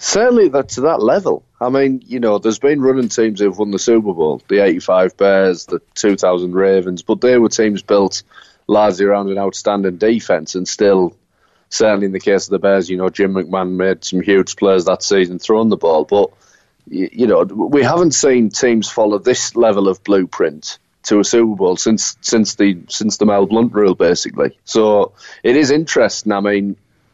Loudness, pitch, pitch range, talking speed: -14 LUFS, 100 Hz, 95-110 Hz, 190 wpm